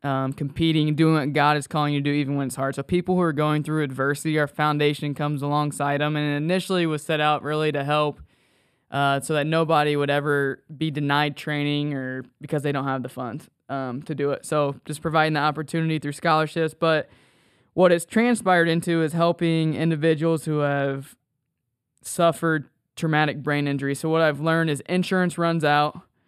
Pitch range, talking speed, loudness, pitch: 145-160 Hz, 190 wpm, -23 LUFS, 150 Hz